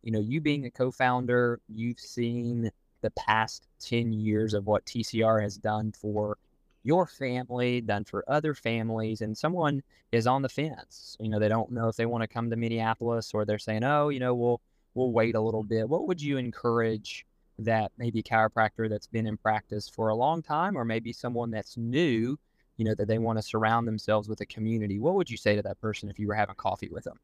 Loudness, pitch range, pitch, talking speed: -29 LUFS, 110-125 Hz, 115 Hz, 220 wpm